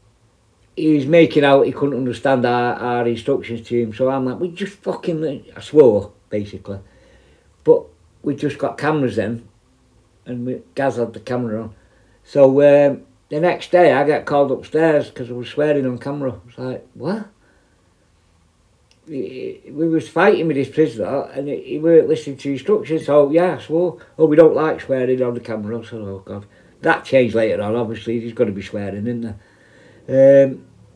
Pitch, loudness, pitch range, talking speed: 125 Hz, -18 LUFS, 115-145 Hz, 180 wpm